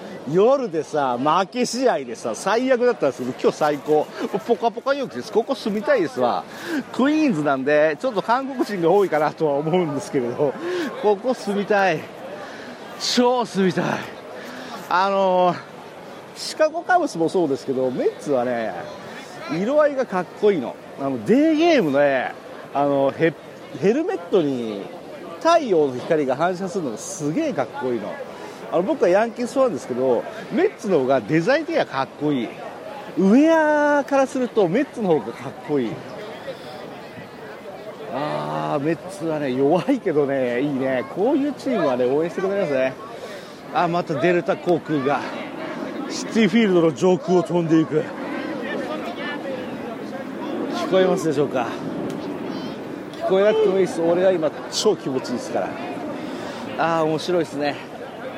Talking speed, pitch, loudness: 310 characters per minute, 195 Hz, -21 LUFS